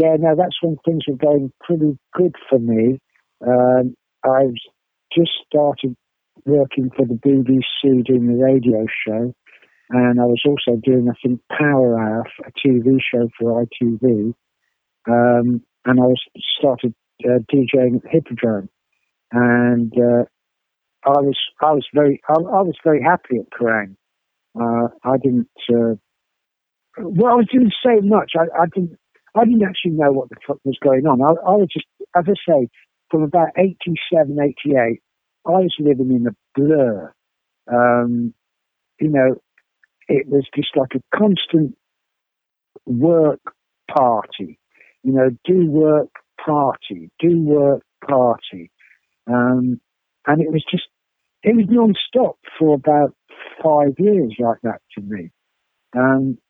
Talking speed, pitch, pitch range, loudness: 145 wpm, 135 Hz, 120-160 Hz, -17 LUFS